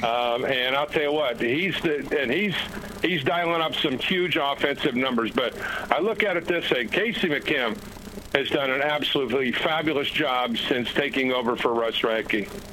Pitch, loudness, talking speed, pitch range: 140 Hz, -24 LUFS, 180 wpm, 125-155 Hz